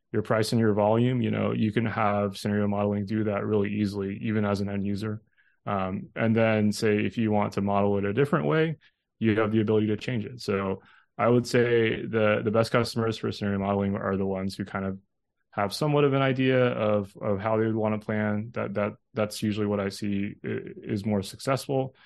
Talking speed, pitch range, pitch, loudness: 220 wpm, 100-115 Hz, 105 Hz, -27 LUFS